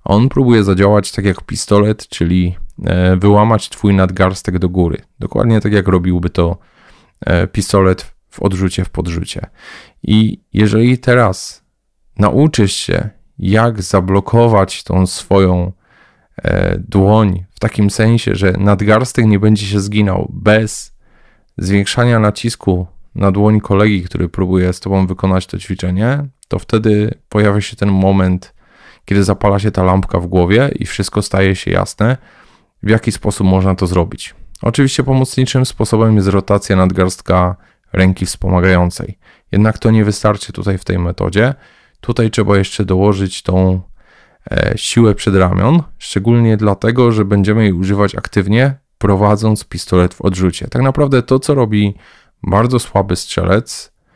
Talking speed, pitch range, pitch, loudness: 135 wpm, 95-110 Hz, 100 Hz, -13 LUFS